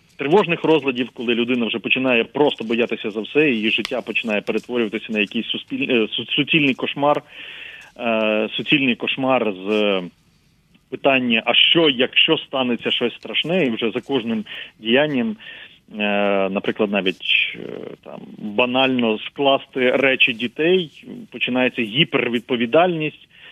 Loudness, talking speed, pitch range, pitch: -19 LUFS, 105 wpm, 115-145 Hz, 125 Hz